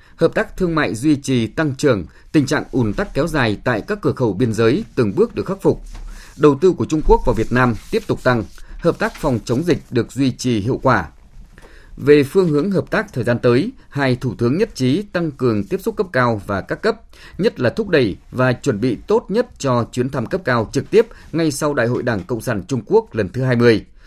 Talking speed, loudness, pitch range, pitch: 240 wpm, -18 LUFS, 120-160 Hz, 130 Hz